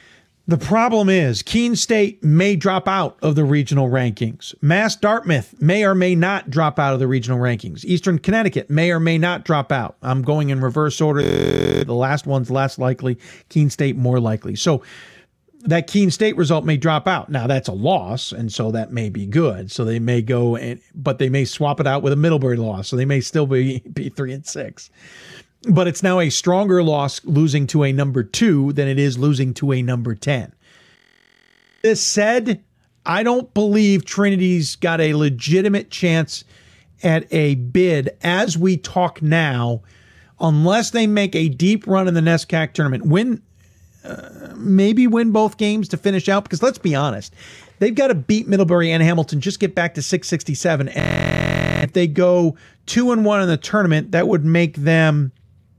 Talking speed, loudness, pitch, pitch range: 185 wpm, -18 LUFS, 160 Hz, 135-190 Hz